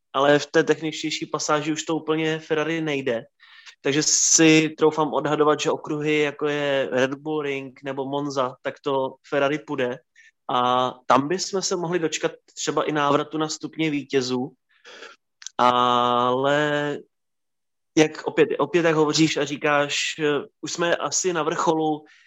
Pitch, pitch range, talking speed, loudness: 150 Hz, 140-155 Hz, 140 wpm, -22 LUFS